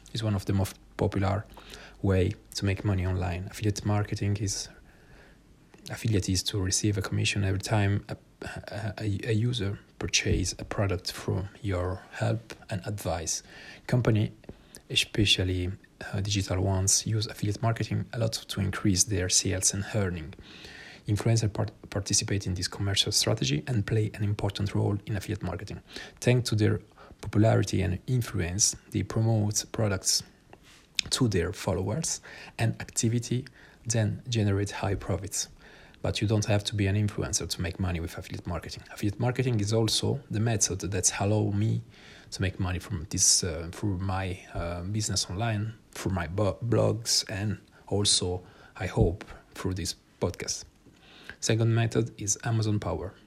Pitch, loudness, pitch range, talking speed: 105 Hz, -28 LUFS, 95-110 Hz, 150 wpm